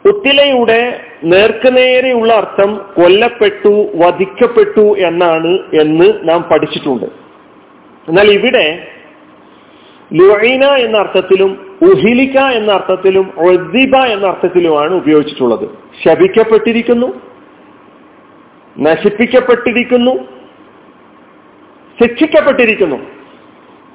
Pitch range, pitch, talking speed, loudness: 185-255 Hz, 220 Hz, 60 wpm, -10 LUFS